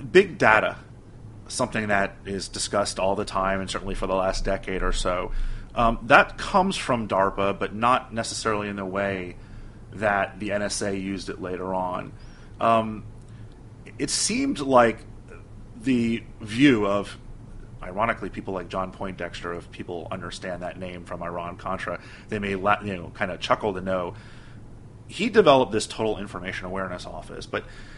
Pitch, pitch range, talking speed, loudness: 105 Hz, 95-115 Hz, 155 wpm, -25 LUFS